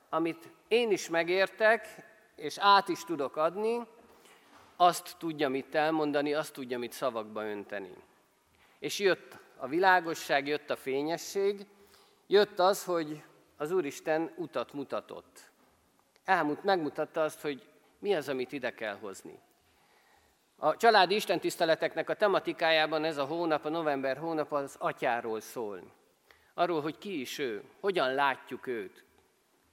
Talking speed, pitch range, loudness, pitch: 130 wpm, 150-200 Hz, -31 LUFS, 165 Hz